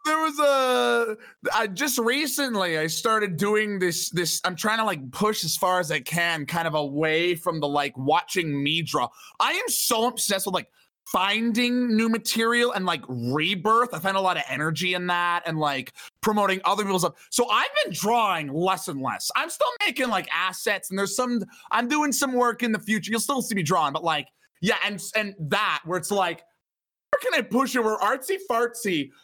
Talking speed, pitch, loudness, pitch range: 205 wpm, 200 Hz, -24 LUFS, 175-240 Hz